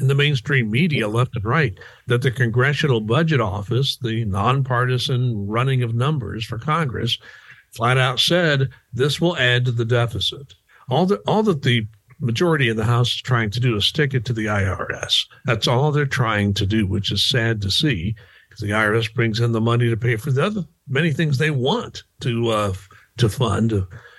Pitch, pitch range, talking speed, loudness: 120 Hz, 110-135 Hz, 195 wpm, -20 LUFS